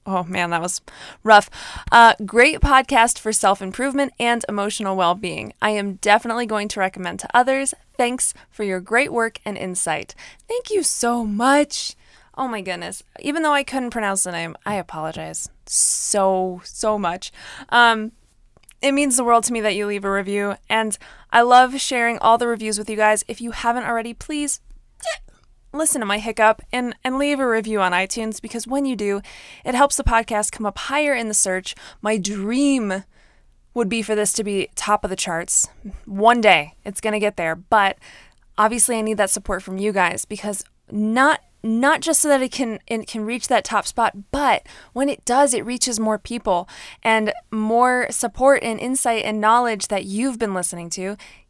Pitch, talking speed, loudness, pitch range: 220 Hz, 185 wpm, -19 LUFS, 200-245 Hz